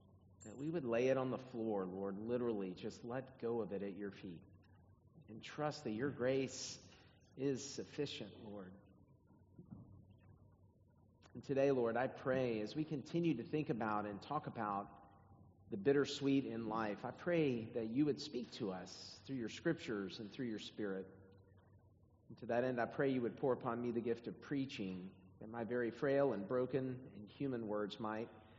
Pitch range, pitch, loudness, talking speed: 100-130 Hz, 115 Hz, -41 LUFS, 175 wpm